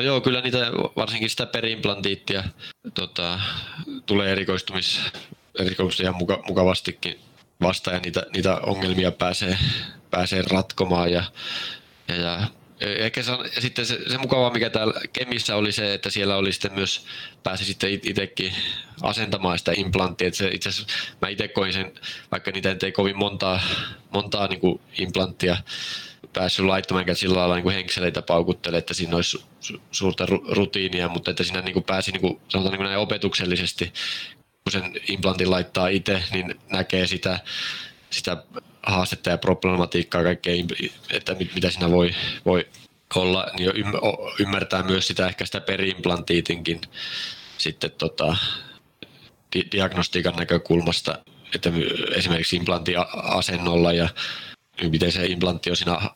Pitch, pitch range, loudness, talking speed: 95 Hz, 90-100 Hz, -24 LUFS, 130 wpm